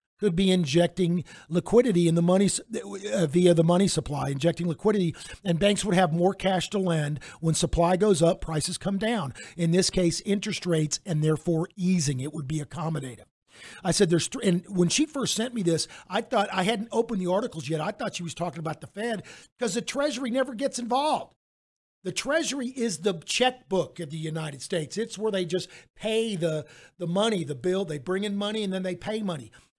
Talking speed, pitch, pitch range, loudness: 205 wpm, 180 Hz, 165-210 Hz, -26 LUFS